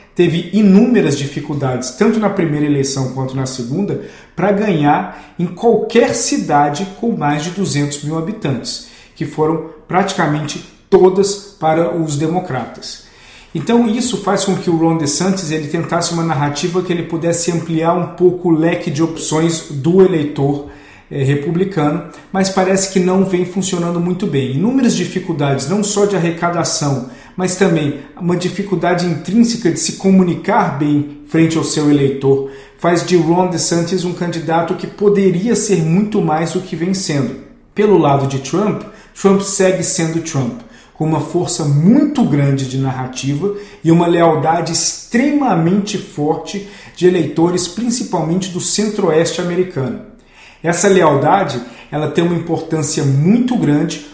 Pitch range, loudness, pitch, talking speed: 150-190 Hz, -15 LUFS, 170 Hz, 145 wpm